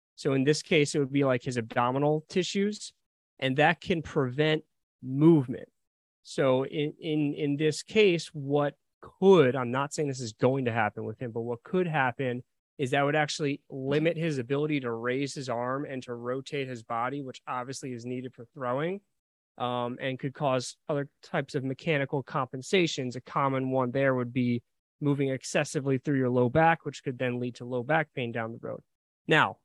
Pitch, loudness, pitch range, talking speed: 135 Hz, -29 LUFS, 125-150 Hz, 190 wpm